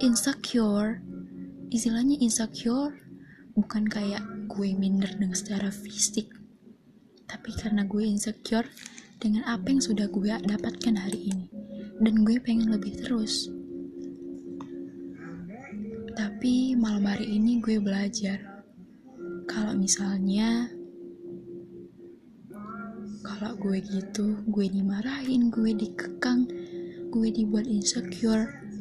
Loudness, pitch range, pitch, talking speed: -28 LUFS, 195-225 Hz, 210 Hz, 95 wpm